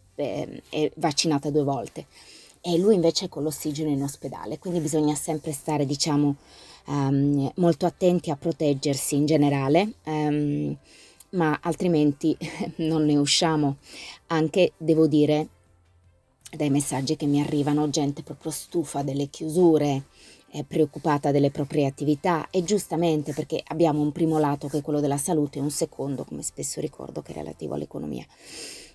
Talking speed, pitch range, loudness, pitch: 145 wpm, 145-160 Hz, -25 LUFS, 150 Hz